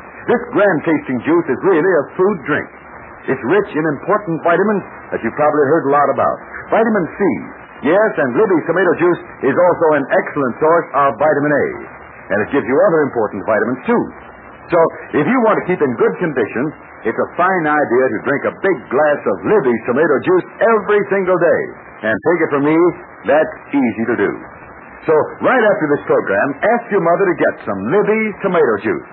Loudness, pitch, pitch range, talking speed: -15 LUFS, 185 Hz, 155-220 Hz, 190 wpm